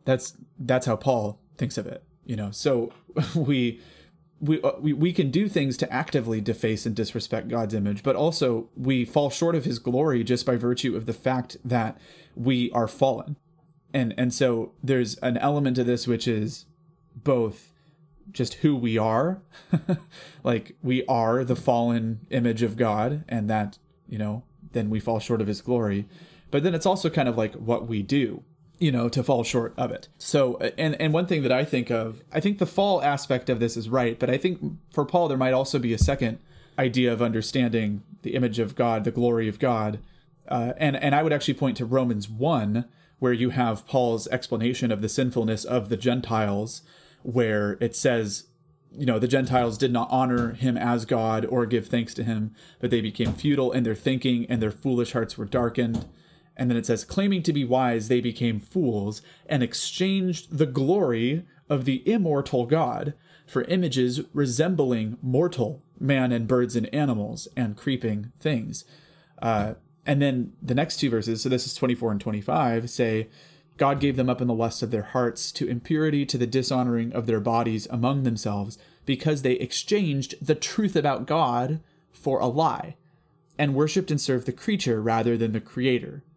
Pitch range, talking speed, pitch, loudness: 115-150 Hz, 190 wpm, 125 Hz, -25 LUFS